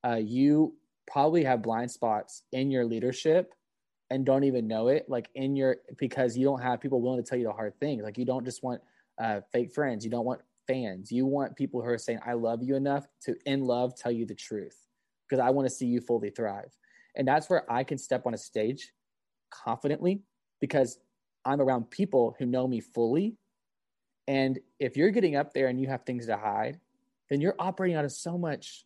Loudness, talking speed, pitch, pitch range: -30 LUFS, 215 wpm, 130 Hz, 120-140 Hz